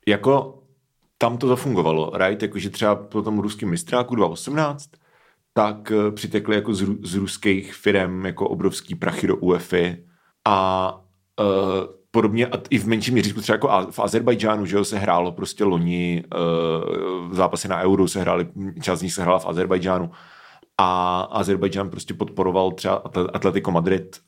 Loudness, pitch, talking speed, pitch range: -22 LUFS, 100 Hz, 170 wpm, 95-110 Hz